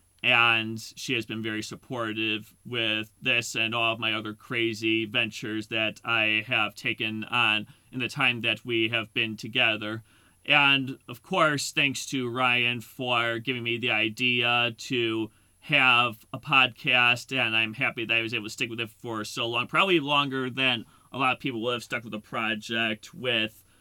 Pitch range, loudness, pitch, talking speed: 110-125 Hz, -25 LUFS, 115 Hz, 180 wpm